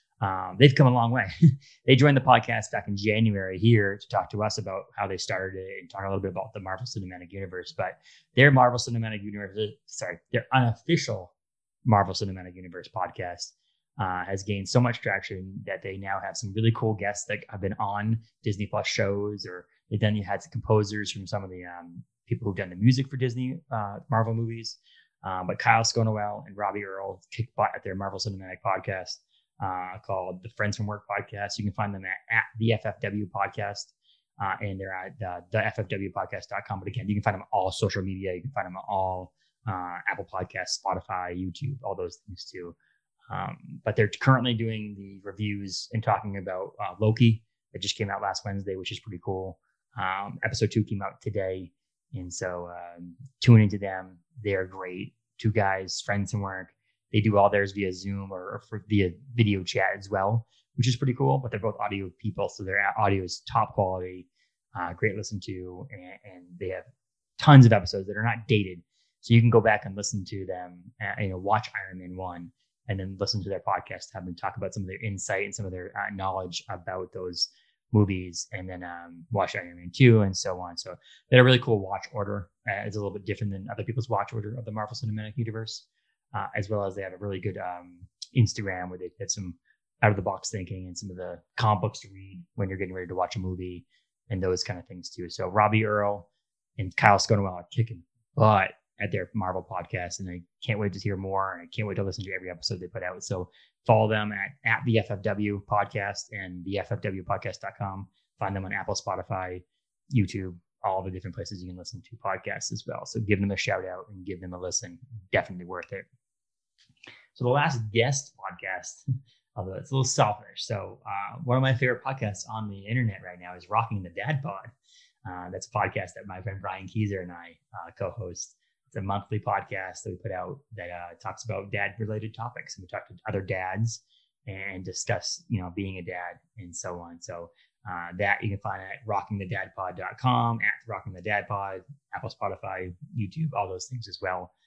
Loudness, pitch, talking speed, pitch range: -28 LUFS, 100 Hz, 215 wpm, 95-115 Hz